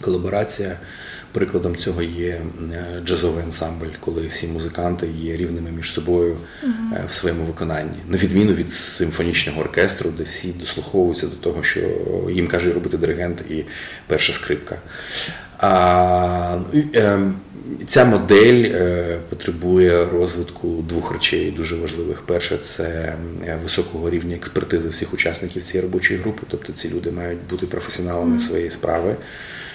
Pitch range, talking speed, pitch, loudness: 85-90 Hz, 120 wpm, 85 Hz, -20 LUFS